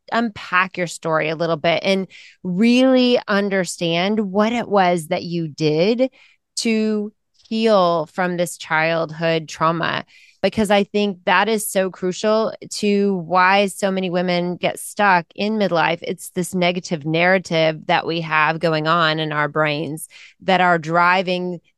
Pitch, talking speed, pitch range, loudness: 180 Hz, 145 wpm, 165-205 Hz, -19 LUFS